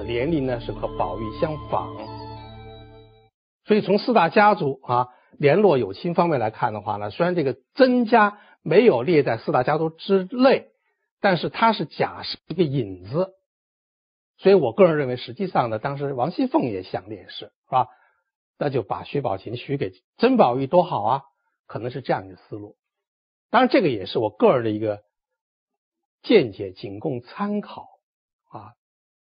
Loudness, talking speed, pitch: -22 LUFS, 245 characters per minute, 160 Hz